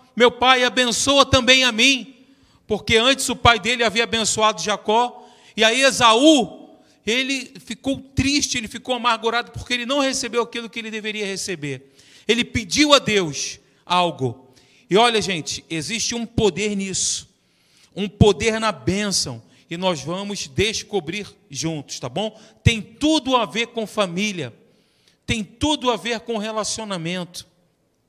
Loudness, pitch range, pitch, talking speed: -19 LUFS, 185-240 Hz, 220 Hz, 145 wpm